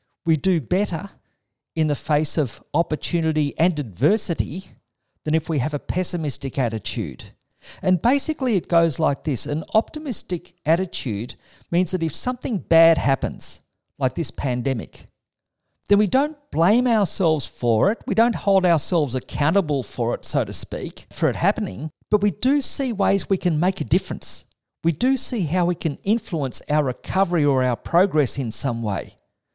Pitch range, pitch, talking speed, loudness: 135-195 Hz, 165 Hz, 160 wpm, -22 LUFS